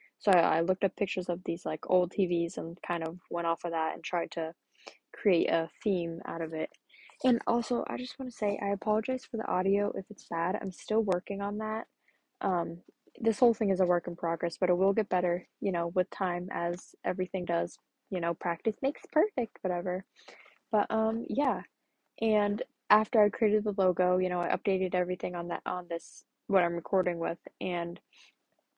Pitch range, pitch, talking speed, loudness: 175-215 Hz, 185 Hz, 200 wpm, -31 LUFS